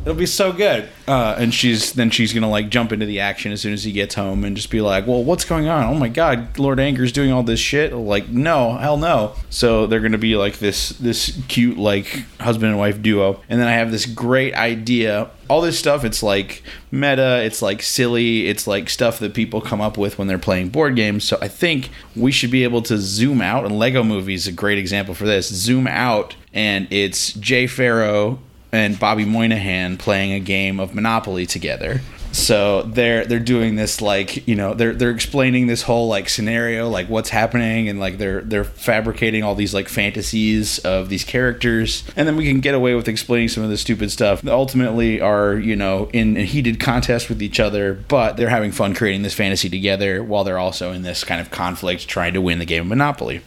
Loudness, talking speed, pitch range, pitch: -18 LUFS, 220 wpm, 100-120 Hz, 110 Hz